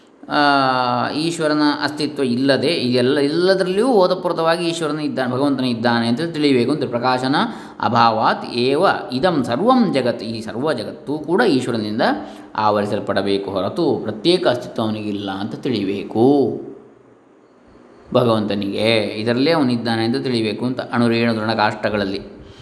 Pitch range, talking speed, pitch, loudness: 110-145 Hz, 110 wpm, 125 Hz, -18 LUFS